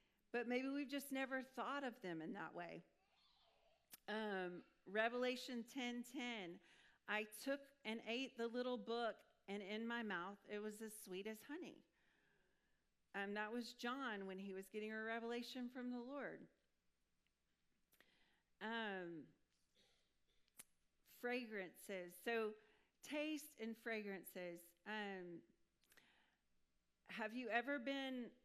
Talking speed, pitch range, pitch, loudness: 120 wpm, 185-245 Hz, 220 Hz, -48 LUFS